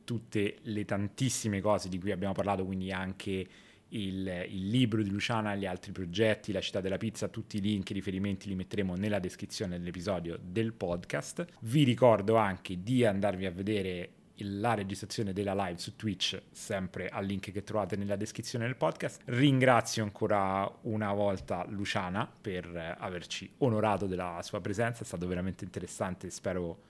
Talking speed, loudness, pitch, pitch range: 165 wpm, -33 LUFS, 100 Hz, 95-110 Hz